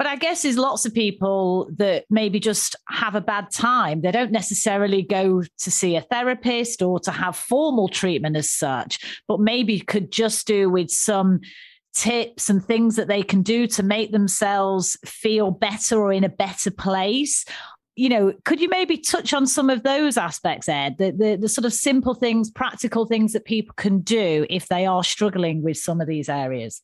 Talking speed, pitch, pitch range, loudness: 195 wpm, 210 Hz, 185-230 Hz, -21 LUFS